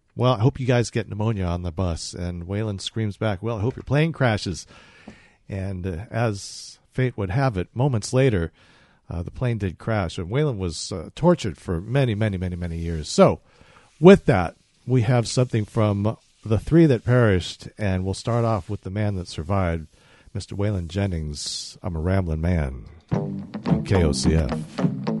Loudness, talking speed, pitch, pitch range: -23 LUFS, 175 wpm, 105 Hz, 90-120 Hz